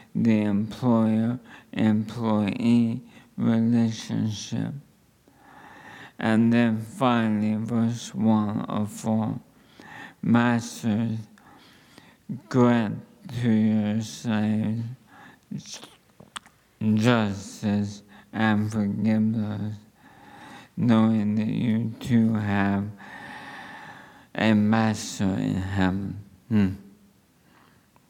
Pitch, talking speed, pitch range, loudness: 110 Hz, 60 wpm, 105-115 Hz, -25 LUFS